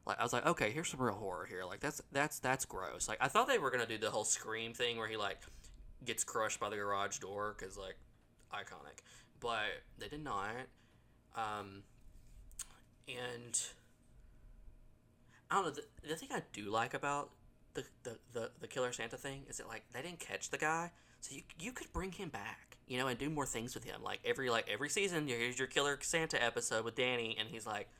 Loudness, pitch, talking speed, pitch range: -39 LUFS, 125 Hz, 210 wpm, 110-145 Hz